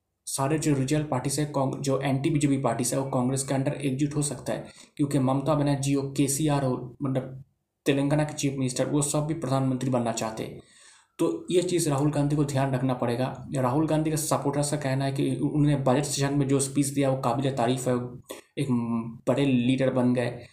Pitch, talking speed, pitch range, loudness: 135 Hz, 200 wpm, 130-145 Hz, -26 LUFS